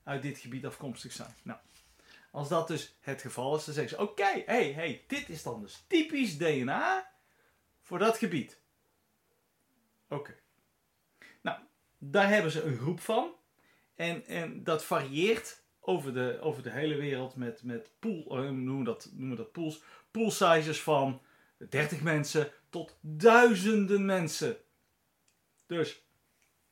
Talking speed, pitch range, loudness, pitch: 145 wpm, 135-205 Hz, -31 LUFS, 155 Hz